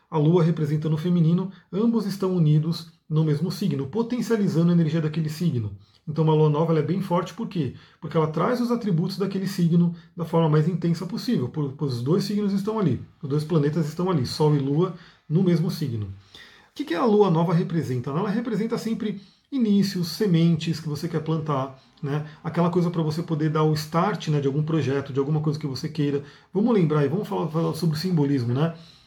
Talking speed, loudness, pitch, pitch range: 200 wpm, -24 LUFS, 165 Hz, 155-185 Hz